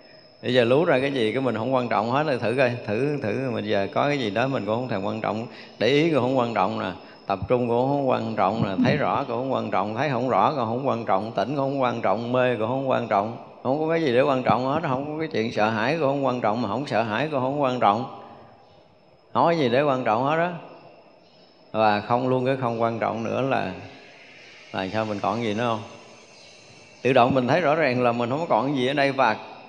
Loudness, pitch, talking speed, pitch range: -23 LUFS, 125 Hz, 270 wpm, 110-135 Hz